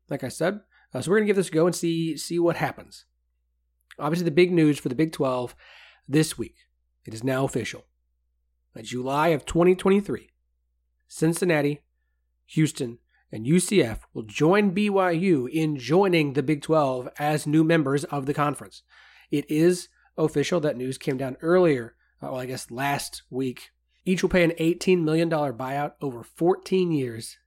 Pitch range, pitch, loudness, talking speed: 125-170 Hz, 145 Hz, -24 LUFS, 165 wpm